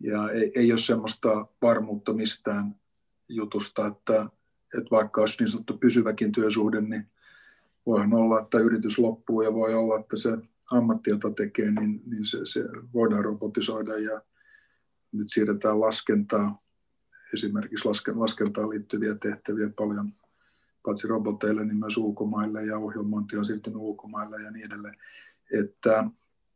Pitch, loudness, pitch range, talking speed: 110 Hz, -27 LUFS, 105-115 Hz, 130 wpm